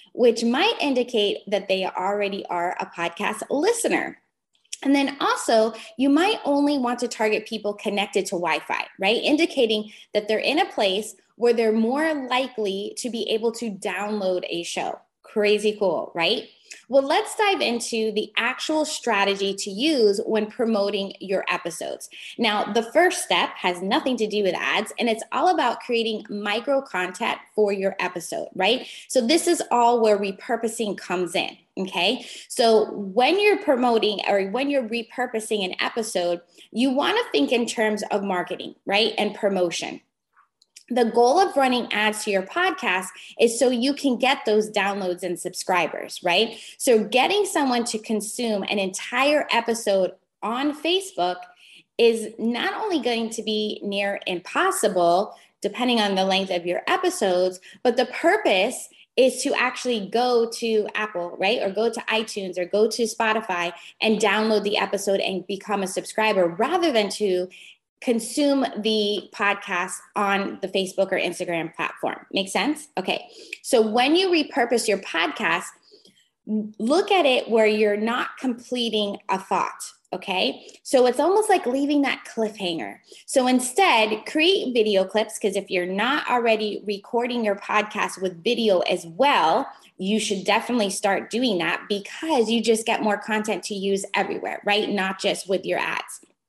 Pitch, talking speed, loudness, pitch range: 220 Hz, 160 wpm, -23 LUFS, 200-250 Hz